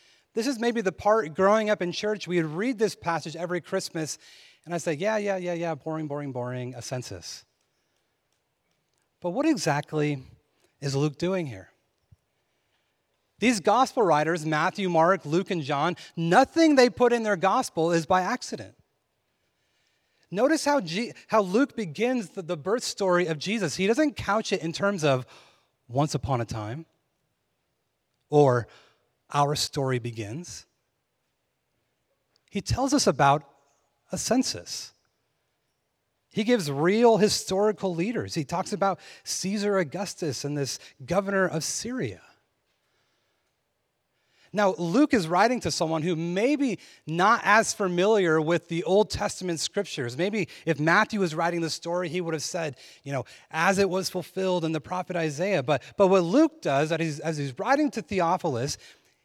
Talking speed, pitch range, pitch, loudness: 150 wpm, 155-205 Hz, 175 Hz, -26 LUFS